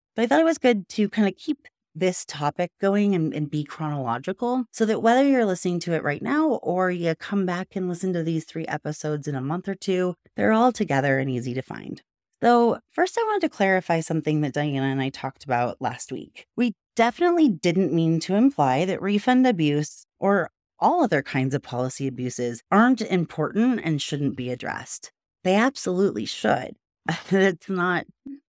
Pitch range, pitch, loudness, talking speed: 150-220 Hz, 180 Hz, -24 LUFS, 190 wpm